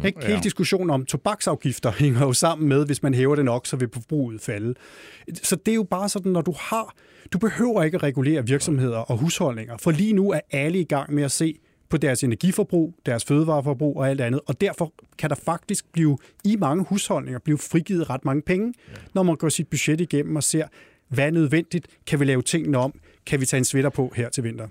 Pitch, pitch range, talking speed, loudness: 155 Hz, 135-180 Hz, 220 wpm, -23 LUFS